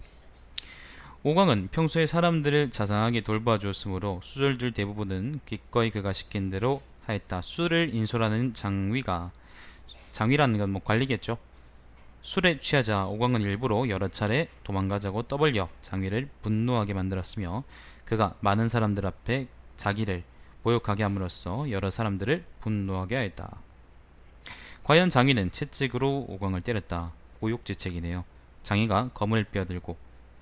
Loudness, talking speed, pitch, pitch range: -28 LUFS, 310 characters per minute, 105 Hz, 90-125 Hz